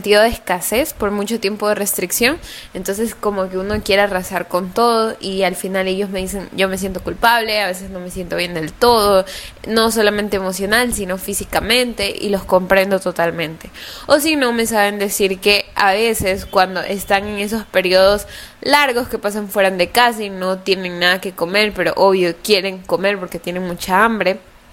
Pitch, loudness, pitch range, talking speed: 195 Hz, -16 LUFS, 185-215 Hz, 185 wpm